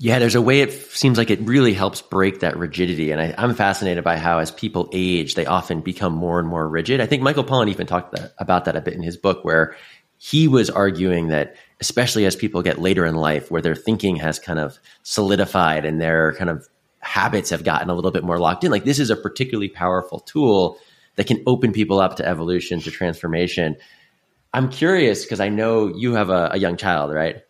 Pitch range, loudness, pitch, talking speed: 85-110 Hz, -20 LUFS, 90 Hz, 225 wpm